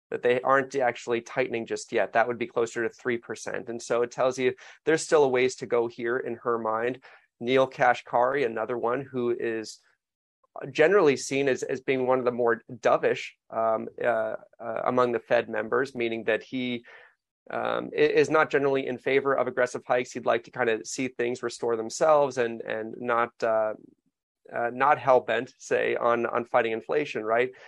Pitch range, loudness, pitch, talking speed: 115-130 Hz, -26 LUFS, 120 Hz, 185 wpm